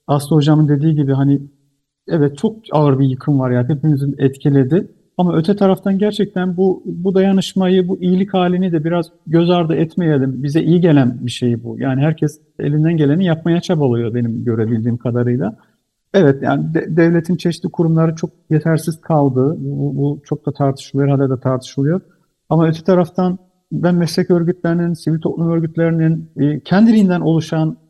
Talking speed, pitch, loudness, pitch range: 155 wpm, 160 Hz, -16 LUFS, 140-175 Hz